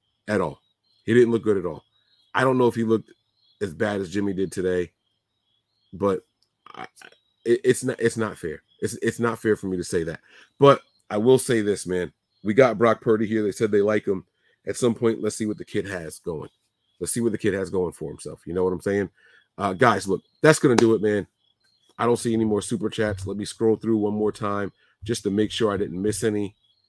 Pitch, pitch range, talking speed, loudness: 105 Hz, 100-115 Hz, 240 wpm, -23 LUFS